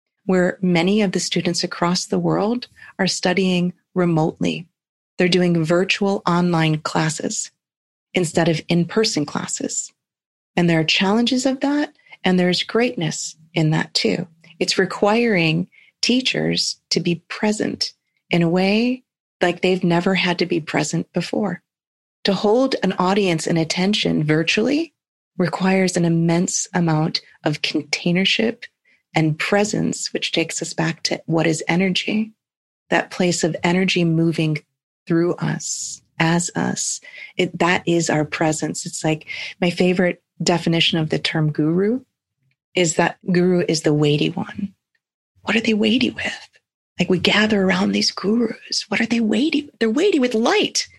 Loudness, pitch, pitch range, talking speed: -19 LUFS, 180 Hz, 165-205 Hz, 145 wpm